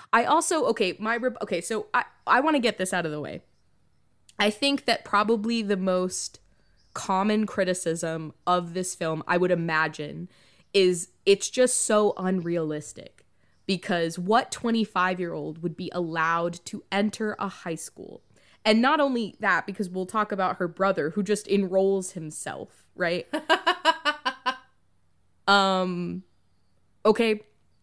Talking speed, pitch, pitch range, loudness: 135 wpm, 190 Hz, 170-215 Hz, -25 LUFS